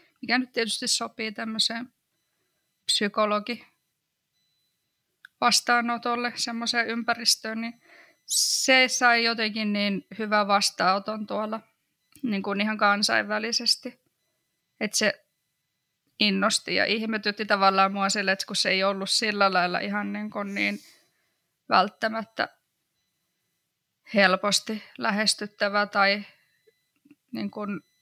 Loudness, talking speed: -24 LUFS, 100 wpm